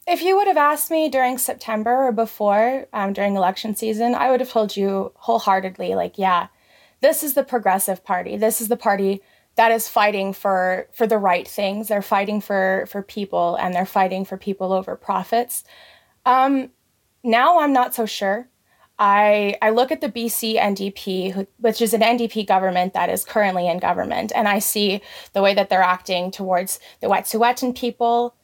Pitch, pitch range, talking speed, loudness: 210 Hz, 195-240 Hz, 180 wpm, -20 LUFS